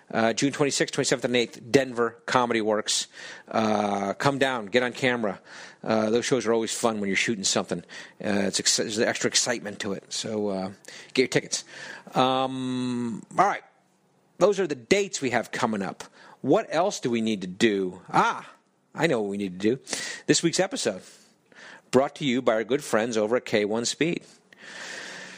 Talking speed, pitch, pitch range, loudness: 185 wpm, 120 Hz, 110-135 Hz, -25 LUFS